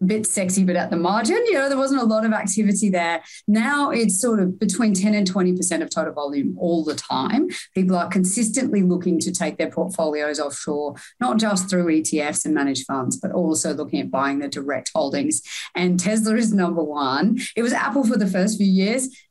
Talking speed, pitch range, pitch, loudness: 210 wpm, 165-220 Hz, 190 Hz, -21 LUFS